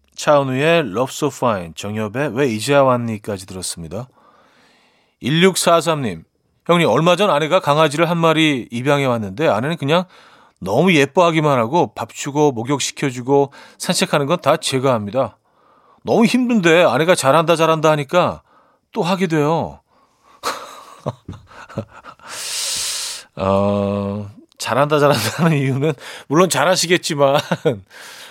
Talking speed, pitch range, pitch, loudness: 260 characters per minute, 125-170 Hz, 145 Hz, -17 LUFS